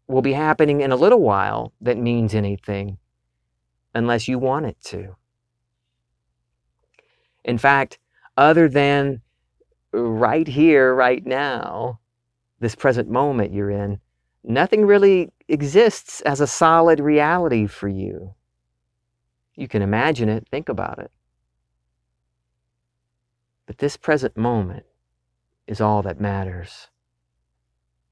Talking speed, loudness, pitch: 110 wpm, -19 LUFS, 115 Hz